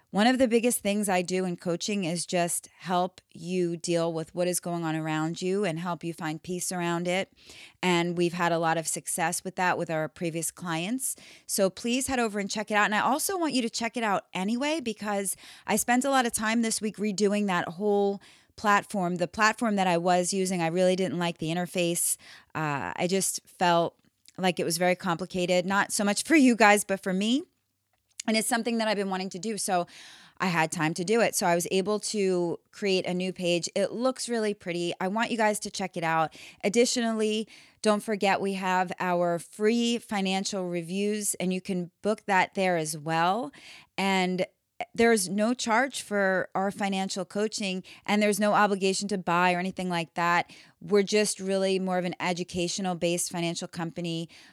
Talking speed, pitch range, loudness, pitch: 200 wpm, 175-210 Hz, -27 LUFS, 190 Hz